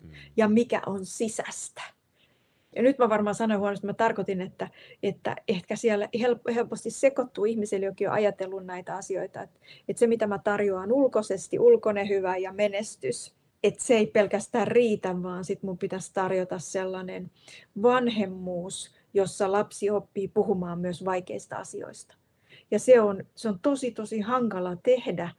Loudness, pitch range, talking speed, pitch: -27 LUFS, 190-230 Hz, 150 wpm, 205 Hz